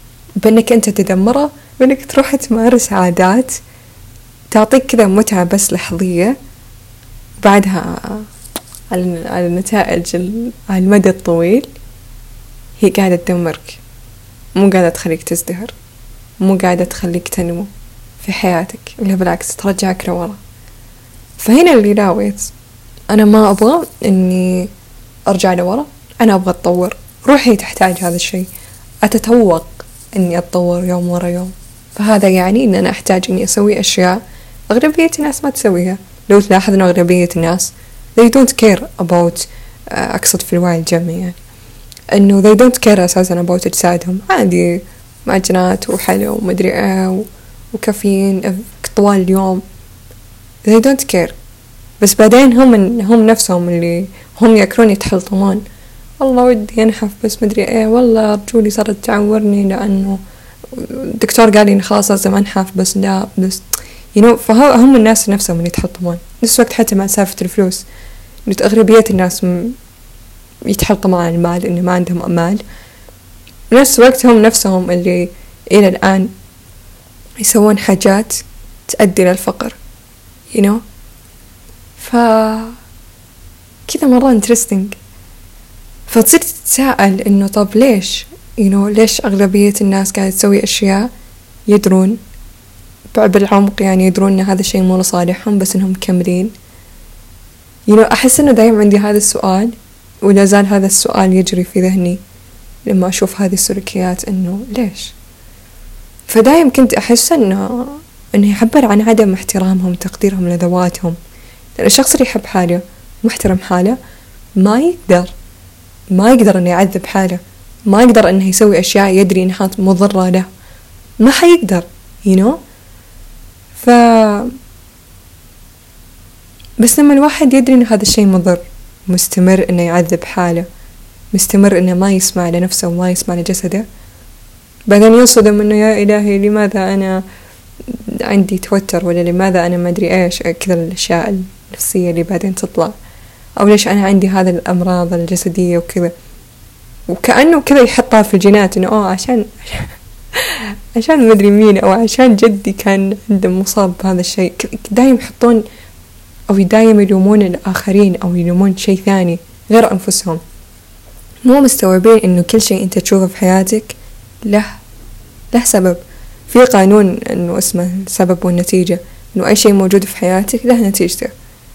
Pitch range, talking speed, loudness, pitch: 175-215 Hz, 125 wpm, -11 LUFS, 190 Hz